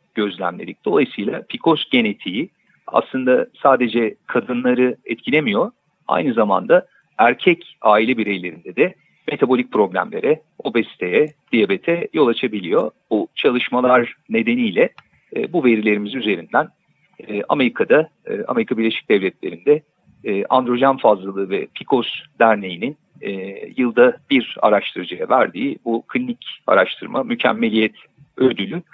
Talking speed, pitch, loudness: 100 wpm, 130 Hz, -18 LUFS